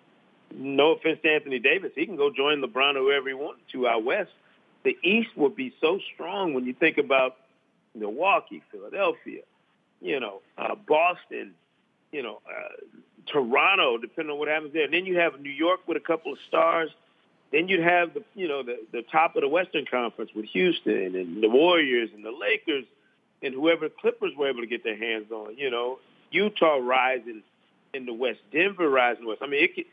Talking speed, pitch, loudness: 200 wpm, 160 Hz, -25 LUFS